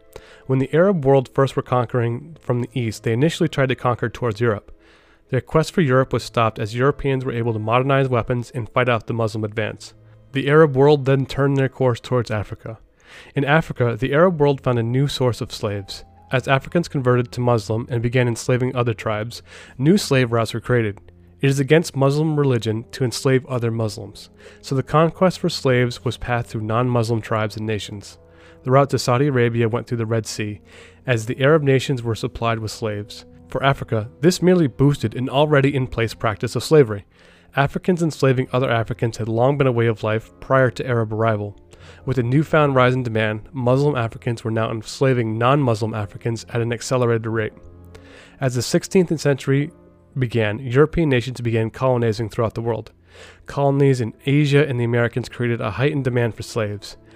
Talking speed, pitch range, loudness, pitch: 185 wpm, 110-135 Hz, -20 LUFS, 125 Hz